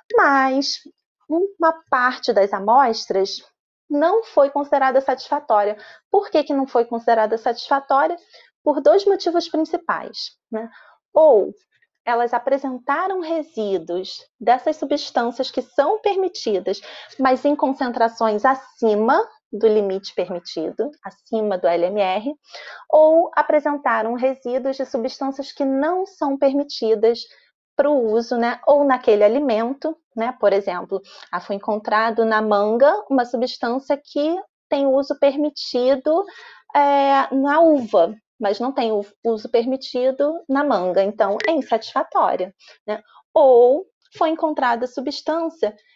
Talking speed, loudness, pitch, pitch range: 115 wpm, -19 LUFS, 265 Hz, 225-300 Hz